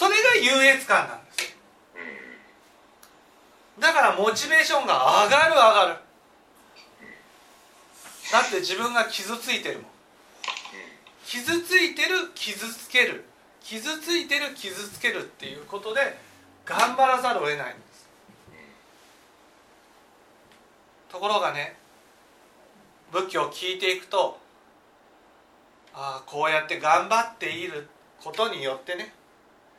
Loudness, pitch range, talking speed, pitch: -23 LUFS, 185-290 Hz, 225 characters per minute, 230 Hz